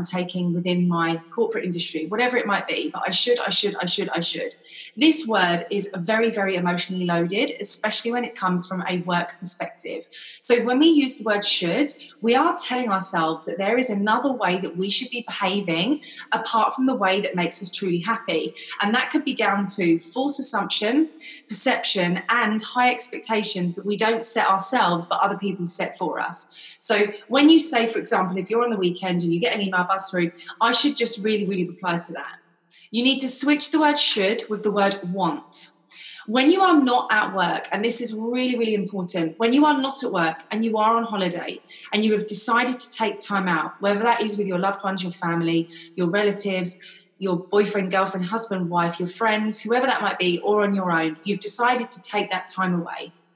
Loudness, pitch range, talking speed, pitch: -22 LUFS, 180-240 Hz, 210 wpm, 205 Hz